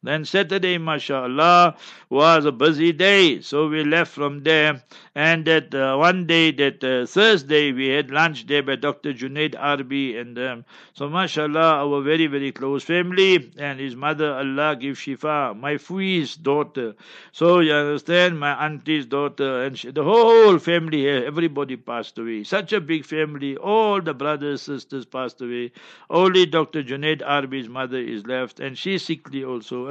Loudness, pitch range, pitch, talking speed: -20 LUFS, 135-165 Hz, 150 Hz, 165 wpm